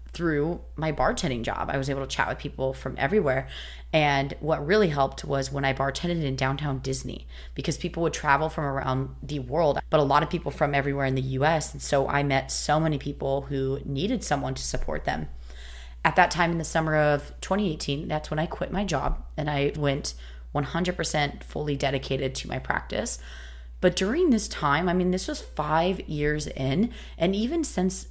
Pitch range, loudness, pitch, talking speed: 135-165 Hz, -26 LUFS, 145 Hz, 195 wpm